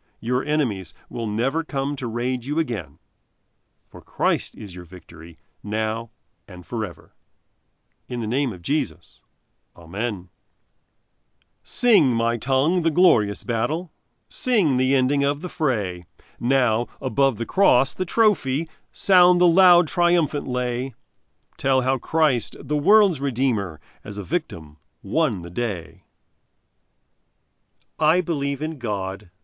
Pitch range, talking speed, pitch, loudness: 100-150 Hz, 125 wpm, 125 Hz, -22 LUFS